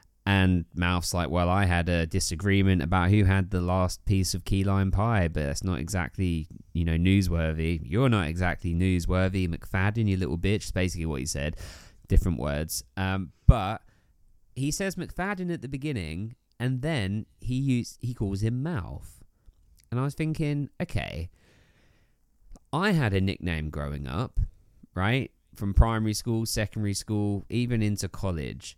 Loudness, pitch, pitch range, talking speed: -28 LUFS, 95 Hz, 85-110 Hz, 155 wpm